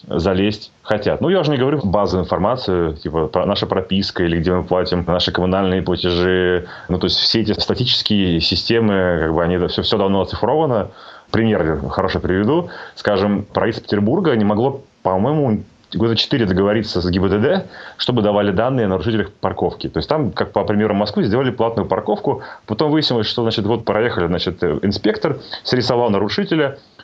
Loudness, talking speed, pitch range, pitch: -18 LUFS, 165 wpm, 90-110 Hz, 100 Hz